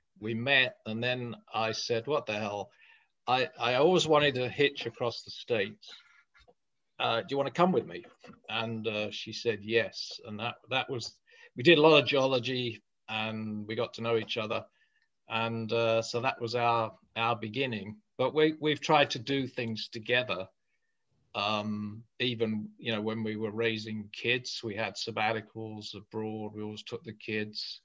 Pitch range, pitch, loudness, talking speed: 110-130 Hz, 115 Hz, -30 LUFS, 175 wpm